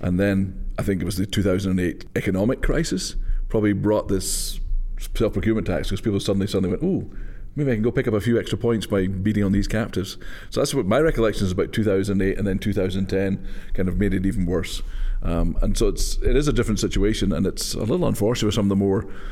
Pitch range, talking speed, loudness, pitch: 95-105 Hz, 225 wpm, -23 LUFS, 100 Hz